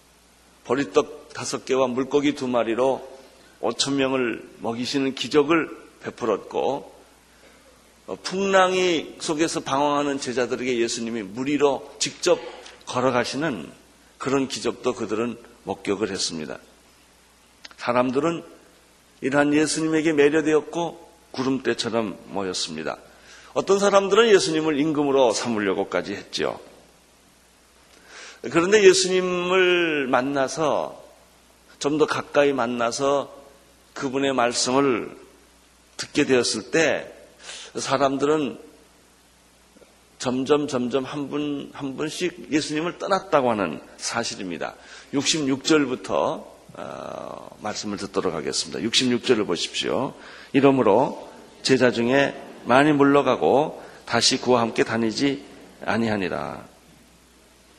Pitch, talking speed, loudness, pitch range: 135 Hz, 240 characters per minute, -23 LUFS, 120-150 Hz